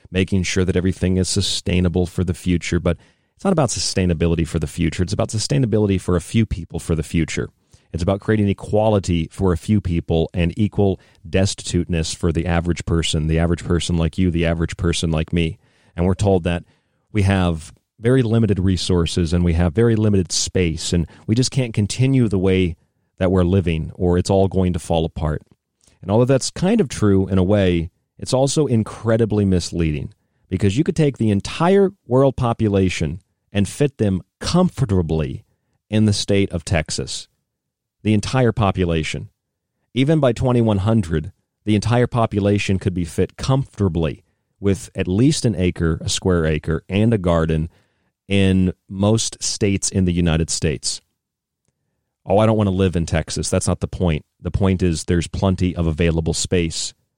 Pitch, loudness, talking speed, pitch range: 95 Hz, -19 LUFS, 175 wpm, 85-110 Hz